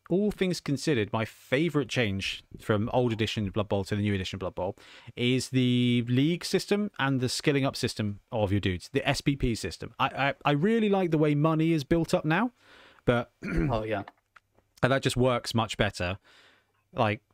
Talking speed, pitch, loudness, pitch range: 185 wpm, 130 Hz, -28 LUFS, 110-160 Hz